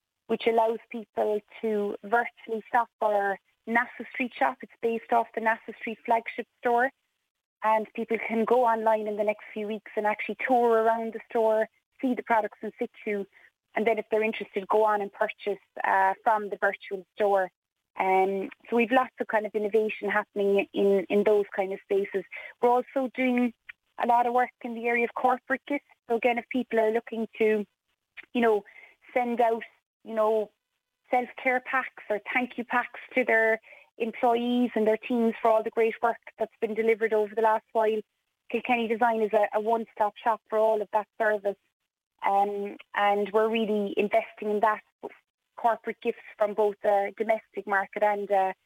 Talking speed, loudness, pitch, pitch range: 180 wpm, -27 LUFS, 225 Hz, 210-235 Hz